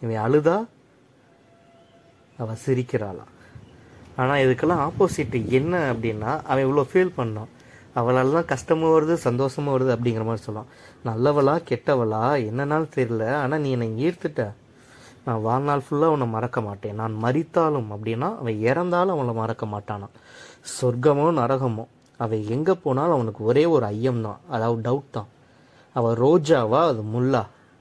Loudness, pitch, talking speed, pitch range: -23 LUFS, 130 Hz, 125 wpm, 115-145 Hz